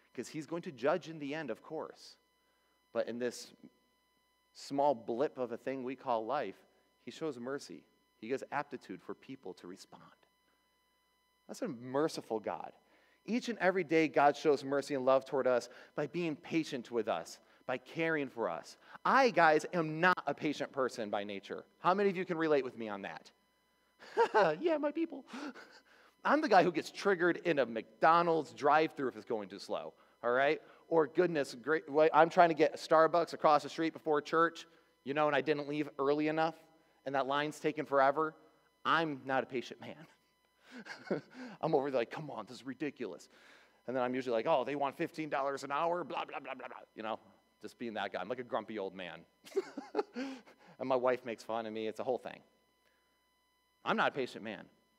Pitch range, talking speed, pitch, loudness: 135-165 Hz, 195 wpm, 150 Hz, -34 LUFS